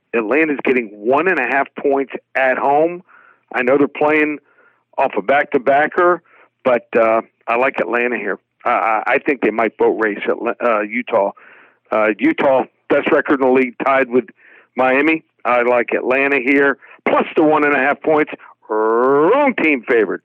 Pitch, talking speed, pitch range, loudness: 140 Hz, 180 wpm, 130-155 Hz, -16 LUFS